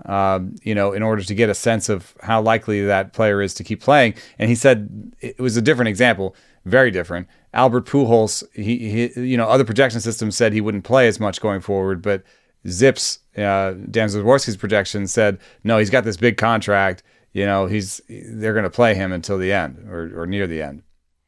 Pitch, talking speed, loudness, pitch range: 105 Hz, 210 wpm, -19 LUFS, 100-115 Hz